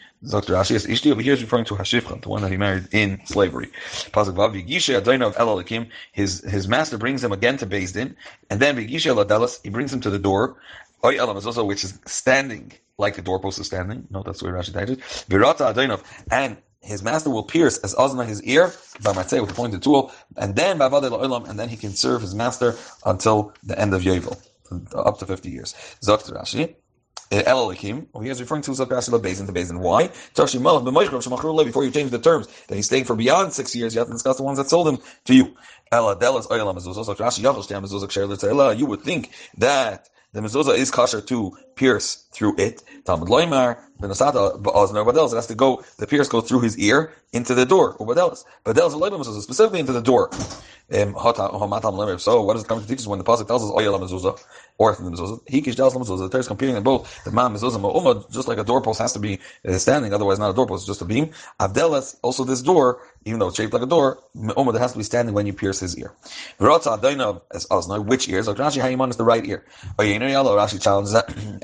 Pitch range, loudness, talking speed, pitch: 100-130 Hz, -21 LUFS, 210 wpm, 115 Hz